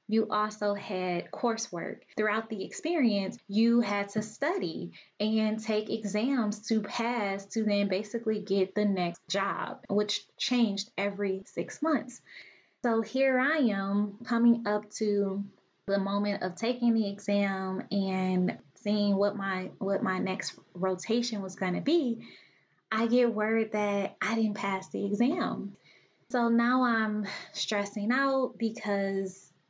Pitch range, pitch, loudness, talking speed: 195-230 Hz, 210 Hz, -30 LUFS, 135 wpm